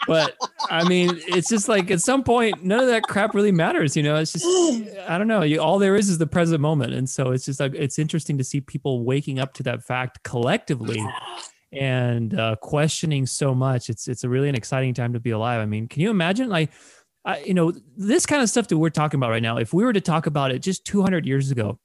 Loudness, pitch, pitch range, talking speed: -22 LUFS, 155 Hz, 130-190 Hz, 255 wpm